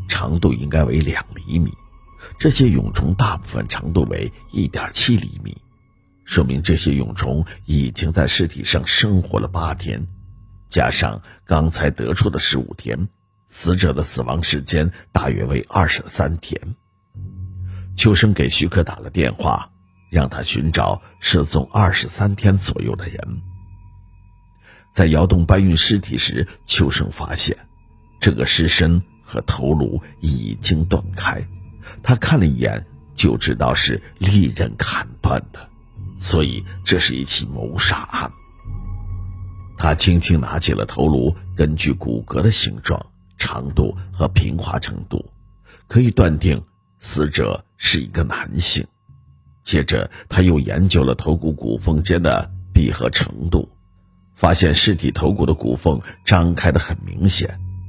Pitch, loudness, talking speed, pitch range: 90 Hz, -18 LUFS, 205 characters per minute, 80-95 Hz